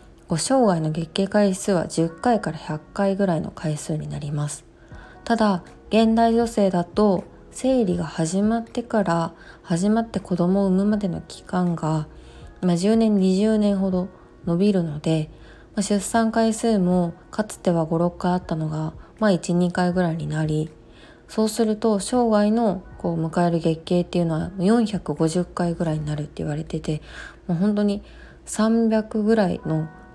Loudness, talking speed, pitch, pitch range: -22 LUFS, 265 characters per minute, 180 Hz, 165-210 Hz